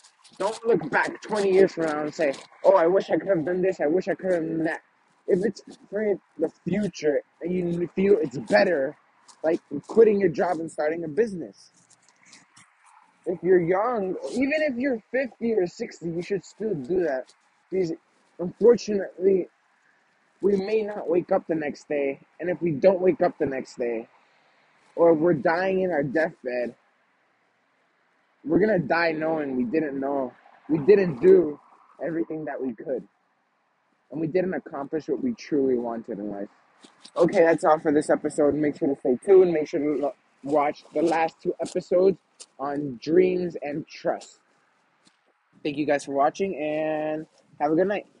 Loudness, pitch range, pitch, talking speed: -24 LUFS, 150-195 Hz, 170 Hz, 175 wpm